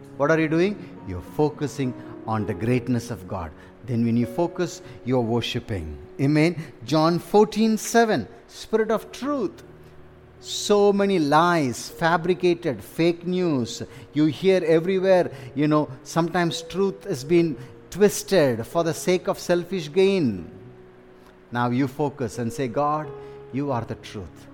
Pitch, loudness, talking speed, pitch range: 150 Hz, -23 LUFS, 135 wpm, 120-180 Hz